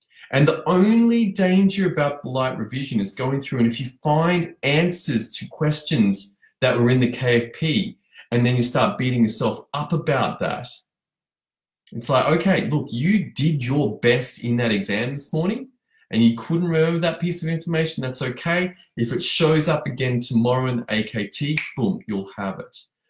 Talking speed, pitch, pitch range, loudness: 175 wpm, 140 Hz, 120-165 Hz, -21 LUFS